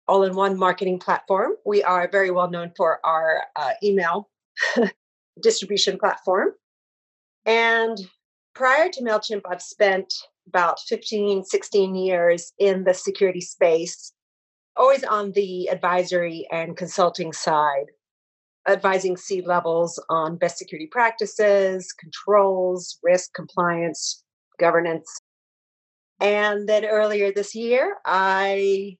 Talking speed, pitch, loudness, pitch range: 110 wpm, 190 Hz, -22 LUFS, 175-205 Hz